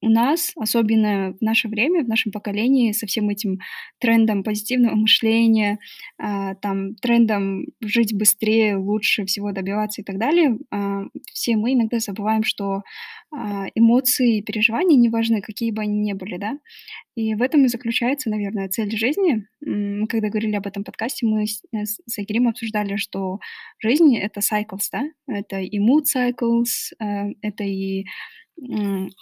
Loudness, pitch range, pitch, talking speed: -21 LUFS, 205-240 Hz, 220 Hz, 145 wpm